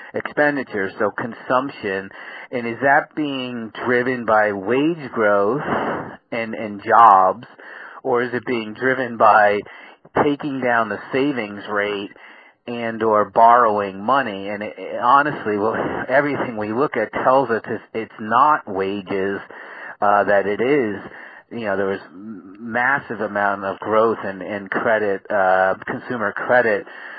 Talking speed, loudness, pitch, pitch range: 135 wpm, -19 LUFS, 110 Hz, 100-125 Hz